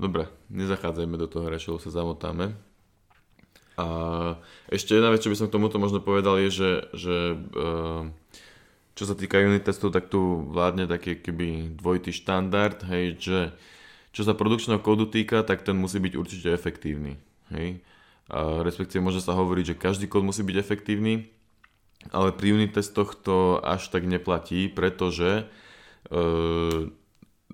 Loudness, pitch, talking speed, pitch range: -26 LUFS, 95 Hz, 150 wpm, 85-100 Hz